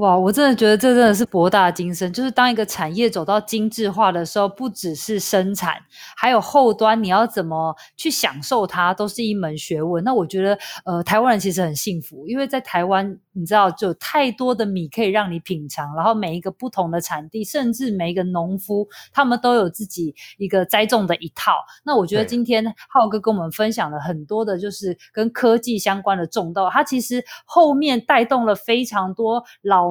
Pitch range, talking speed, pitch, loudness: 180-230 Hz, 305 characters per minute, 210 Hz, -19 LUFS